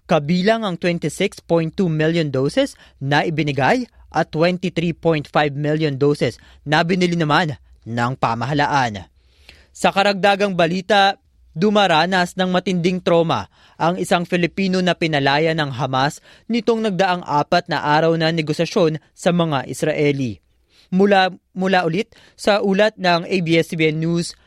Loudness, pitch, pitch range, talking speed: -18 LUFS, 165 Hz, 150-185 Hz, 120 wpm